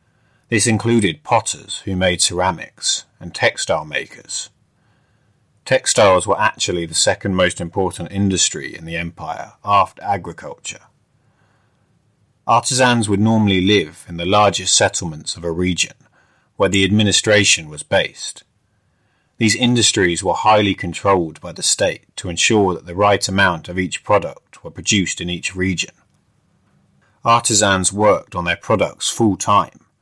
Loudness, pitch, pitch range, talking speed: -17 LUFS, 100 Hz, 90-110 Hz, 135 wpm